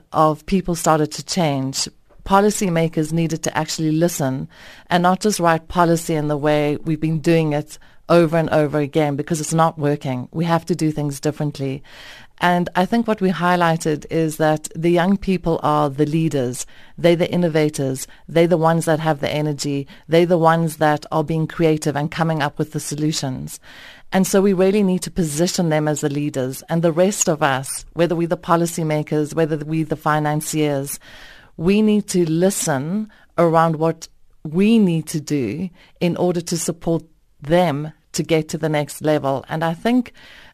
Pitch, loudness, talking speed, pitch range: 160 Hz, -19 LUFS, 180 wpm, 150-175 Hz